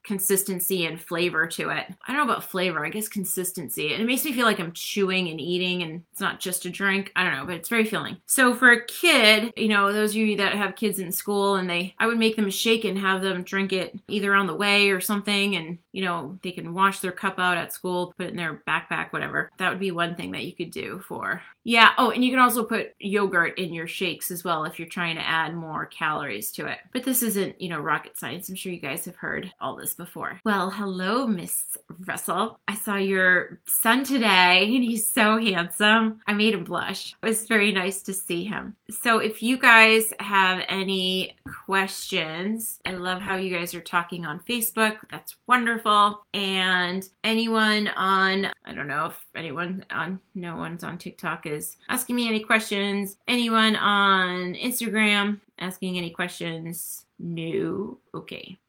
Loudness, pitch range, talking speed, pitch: -23 LUFS, 180-215 Hz, 210 wpm, 195 Hz